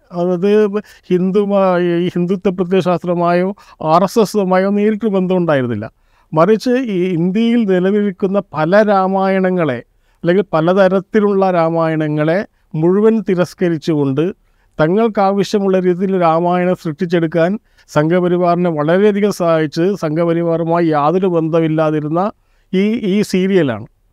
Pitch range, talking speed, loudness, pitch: 165-195 Hz, 85 wpm, -15 LUFS, 180 Hz